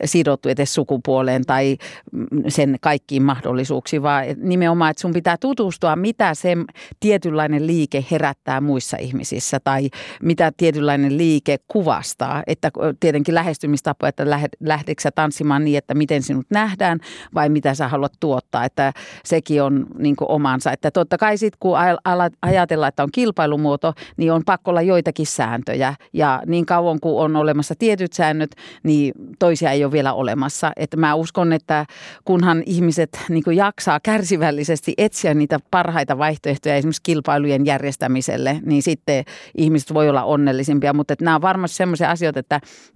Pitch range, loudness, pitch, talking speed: 145-170 Hz, -19 LUFS, 155 Hz, 150 wpm